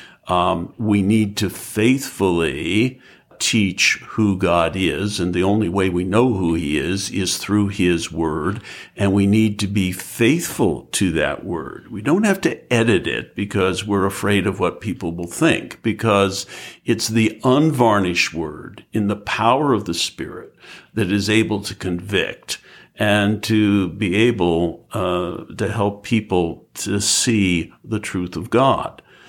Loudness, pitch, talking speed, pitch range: -19 LUFS, 100 Hz, 155 wpm, 90-110 Hz